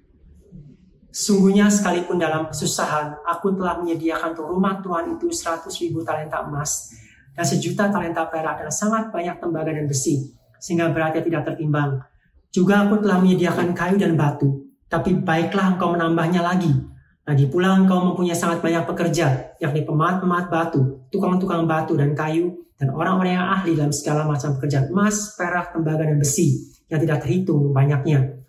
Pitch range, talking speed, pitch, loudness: 150-180 Hz, 150 wpm, 165 Hz, -21 LUFS